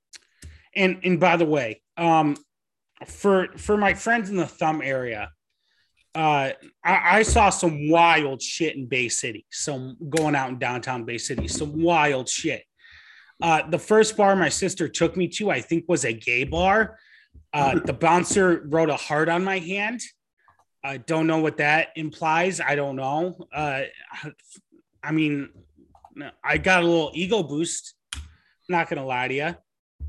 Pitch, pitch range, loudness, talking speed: 160 Hz, 145-180 Hz, -23 LUFS, 160 wpm